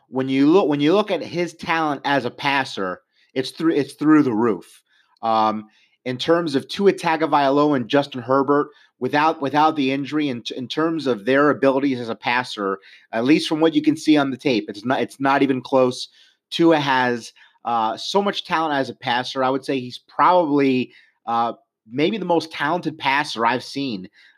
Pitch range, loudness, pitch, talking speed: 125-155 Hz, -20 LUFS, 140 Hz, 195 wpm